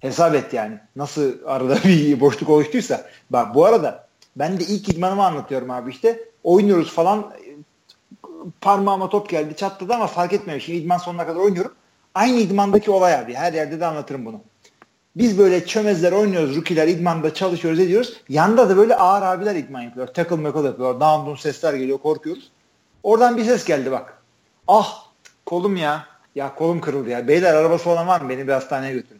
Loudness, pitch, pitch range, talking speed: -19 LUFS, 170 Hz, 145-195 Hz, 170 wpm